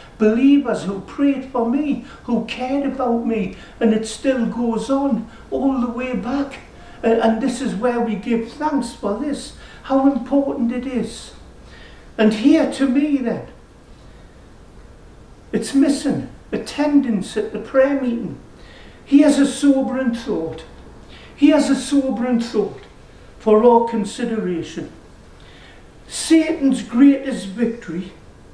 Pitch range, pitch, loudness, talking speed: 225-275 Hz, 245 Hz, -19 LUFS, 125 wpm